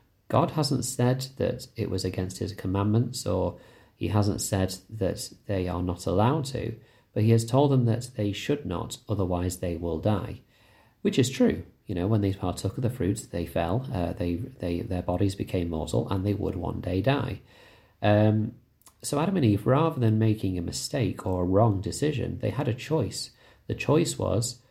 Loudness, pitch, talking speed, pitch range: -27 LUFS, 105 Hz, 190 wpm, 95-120 Hz